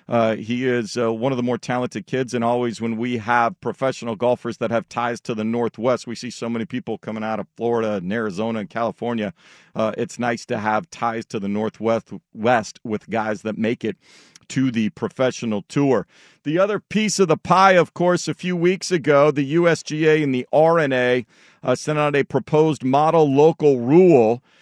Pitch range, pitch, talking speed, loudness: 115-150 Hz, 120 Hz, 195 wpm, -20 LUFS